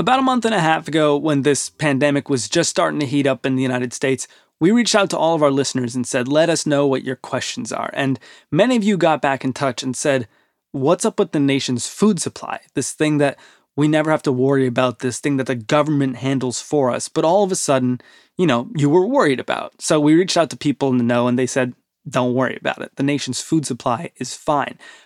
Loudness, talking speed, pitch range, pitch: -19 LUFS, 250 wpm, 130-155 Hz, 140 Hz